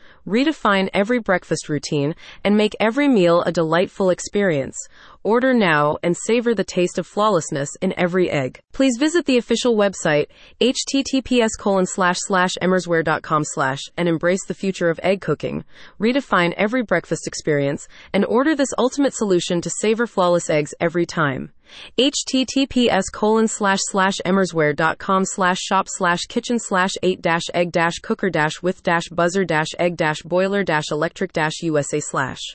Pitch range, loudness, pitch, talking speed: 165-215 Hz, -19 LUFS, 185 Hz, 150 wpm